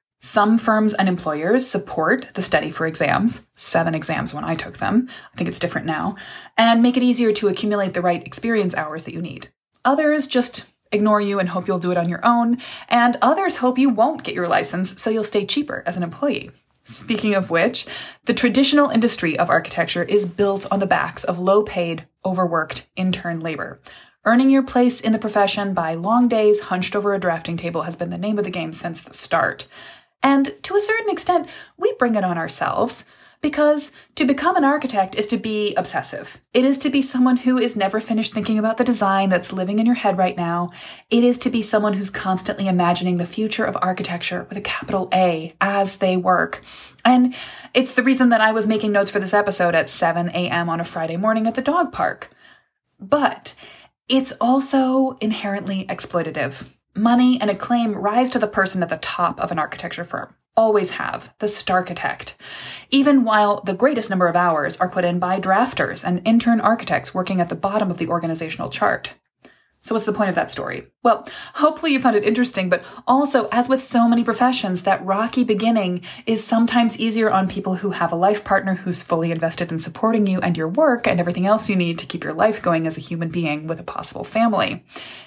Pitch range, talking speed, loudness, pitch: 180-240 Hz, 205 wpm, -19 LUFS, 205 Hz